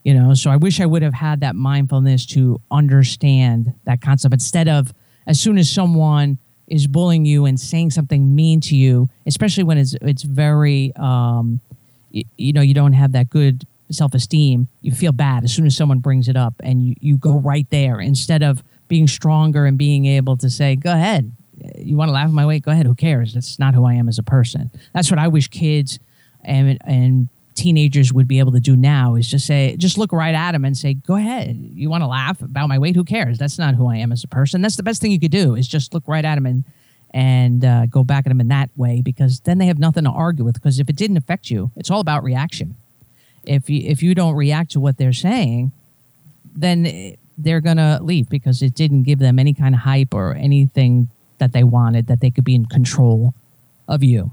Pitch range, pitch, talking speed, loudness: 130-155 Hz, 140 Hz, 235 wpm, -16 LUFS